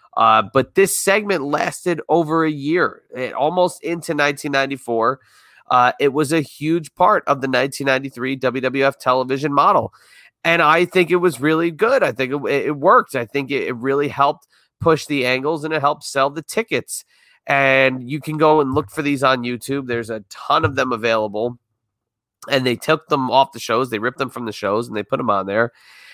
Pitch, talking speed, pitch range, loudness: 140 Hz, 195 wpm, 125-155 Hz, -18 LUFS